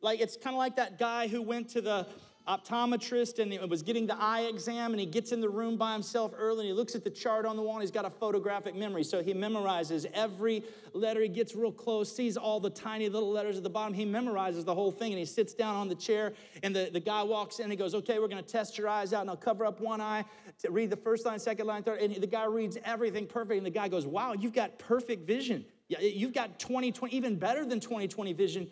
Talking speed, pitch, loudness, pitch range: 265 wpm, 220 Hz, -33 LUFS, 205-230 Hz